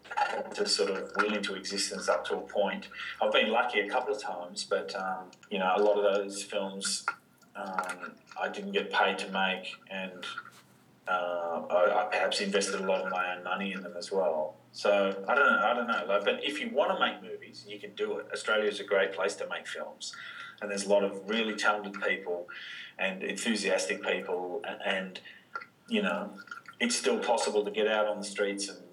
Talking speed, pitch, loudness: 205 wpm, 100 Hz, -30 LUFS